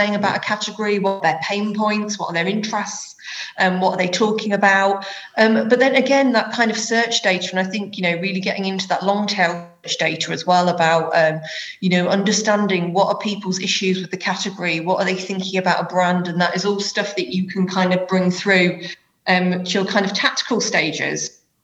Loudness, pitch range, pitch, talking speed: -19 LUFS, 180-205 Hz, 195 Hz, 220 wpm